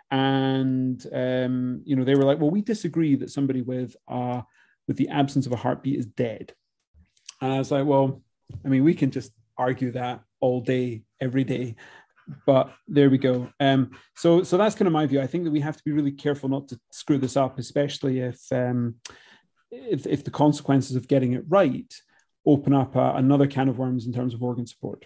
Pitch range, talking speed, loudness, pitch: 125-140 Hz, 210 wpm, -24 LUFS, 135 Hz